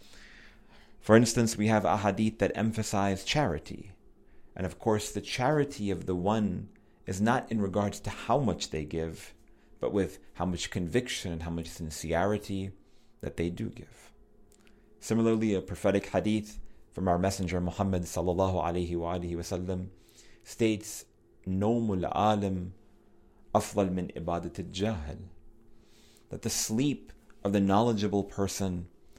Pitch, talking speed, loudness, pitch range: 100 Hz, 120 wpm, -30 LUFS, 90-105 Hz